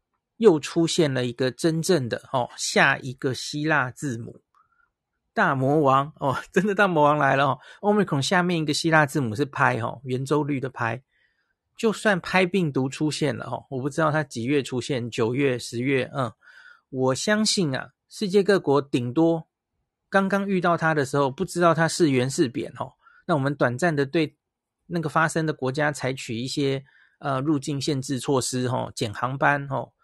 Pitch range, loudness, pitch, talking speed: 130-170 Hz, -24 LUFS, 145 Hz, 255 characters per minute